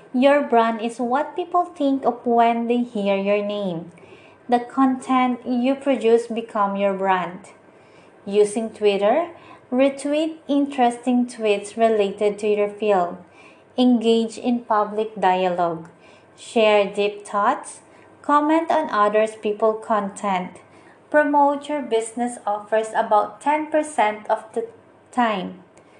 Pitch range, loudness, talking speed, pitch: 205-260 Hz, -21 LUFS, 115 wpm, 230 Hz